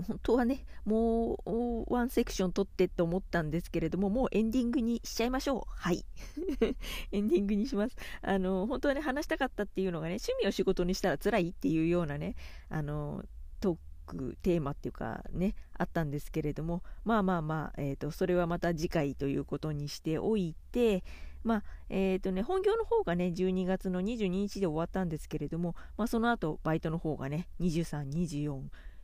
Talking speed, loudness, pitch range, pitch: 380 characters per minute, -33 LUFS, 160-220 Hz, 185 Hz